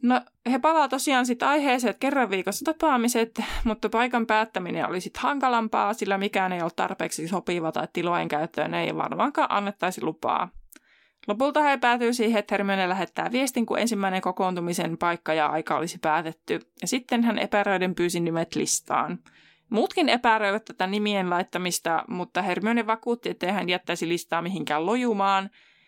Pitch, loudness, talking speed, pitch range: 200 Hz, -25 LUFS, 155 wpm, 175-235 Hz